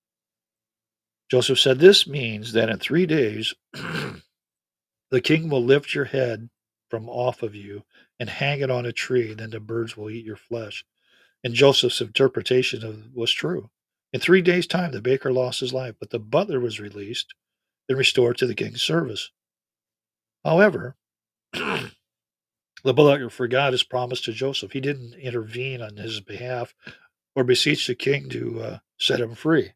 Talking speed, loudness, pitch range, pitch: 160 wpm, -22 LUFS, 110-135 Hz, 125 Hz